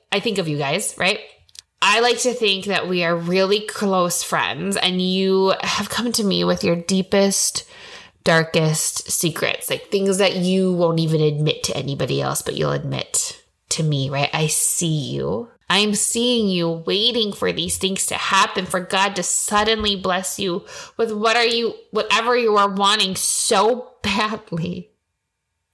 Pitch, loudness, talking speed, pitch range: 195 Hz, -19 LUFS, 170 wpm, 170-220 Hz